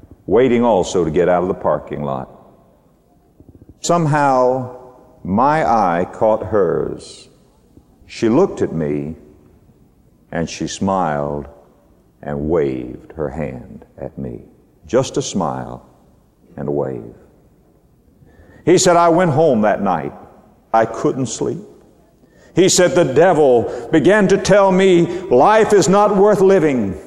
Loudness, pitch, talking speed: -15 LUFS, 115 Hz, 125 wpm